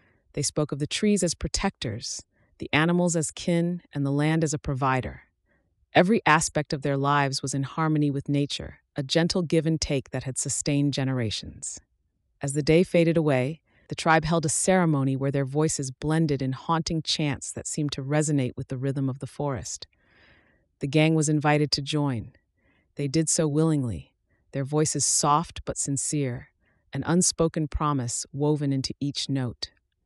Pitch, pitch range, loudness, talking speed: 145 Hz, 135-160 Hz, -25 LUFS, 170 wpm